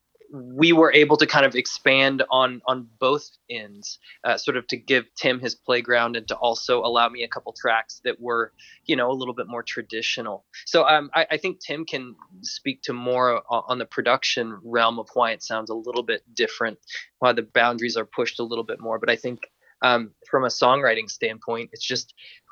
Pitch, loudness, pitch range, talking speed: 120 Hz, -22 LUFS, 115-135 Hz, 205 wpm